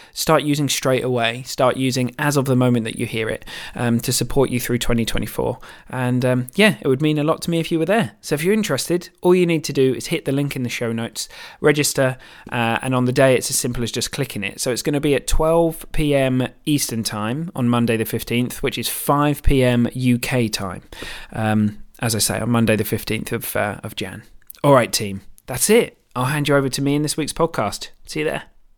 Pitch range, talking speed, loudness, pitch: 115-145 Hz, 240 wpm, -20 LUFS, 125 Hz